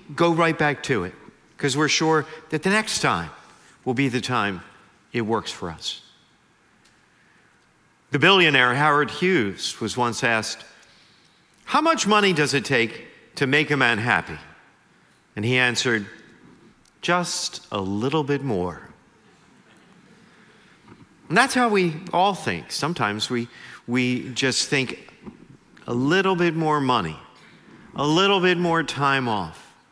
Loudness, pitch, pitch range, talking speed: -22 LUFS, 140 Hz, 115-170 Hz, 135 wpm